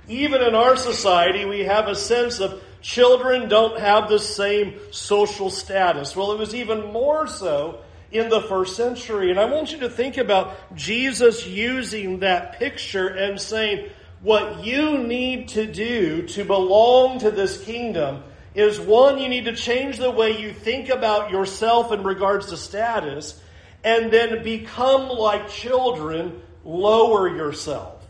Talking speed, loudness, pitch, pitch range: 155 wpm, -20 LUFS, 215 Hz, 195-240 Hz